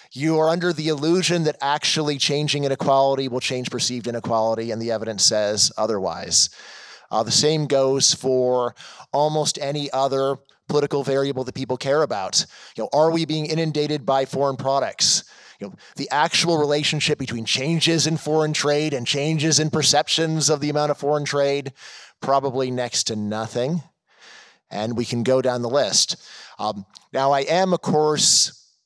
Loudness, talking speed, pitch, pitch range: -21 LUFS, 160 wpm, 140 Hz, 130-155 Hz